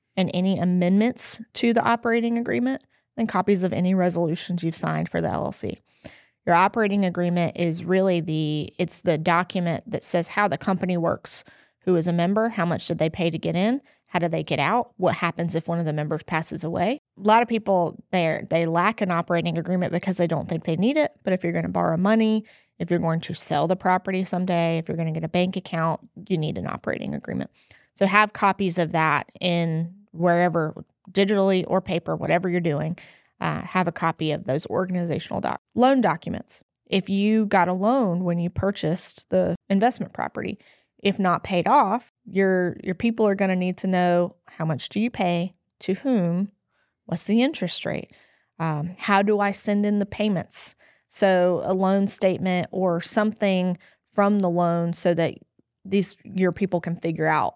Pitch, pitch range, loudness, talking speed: 185 Hz, 170-200 Hz, -23 LUFS, 195 wpm